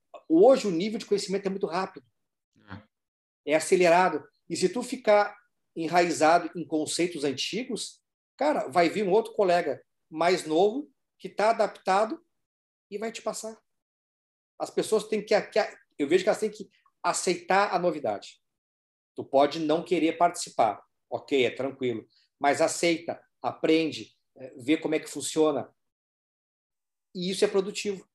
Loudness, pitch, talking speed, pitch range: -26 LUFS, 180 Hz, 140 wpm, 155-210 Hz